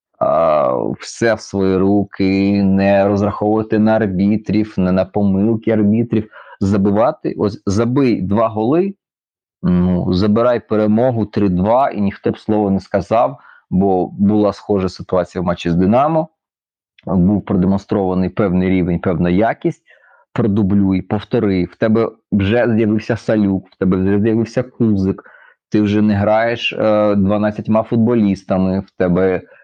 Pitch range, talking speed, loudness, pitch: 95-110 Hz, 125 wpm, -16 LUFS, 100 Hz